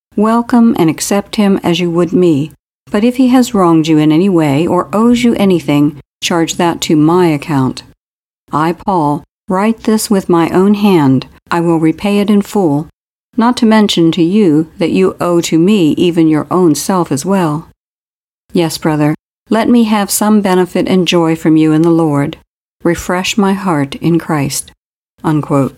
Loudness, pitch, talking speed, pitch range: -11 LUFS, 175 Hz, 175 wpm, 160-200 Hz